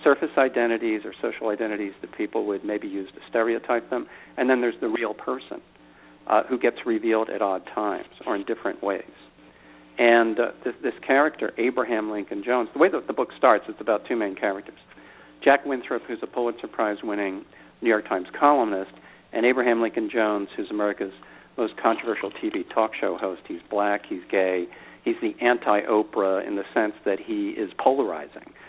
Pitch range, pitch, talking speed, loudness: 105-125 Hz, 115 Hz, 180 wpm, -25 LUFS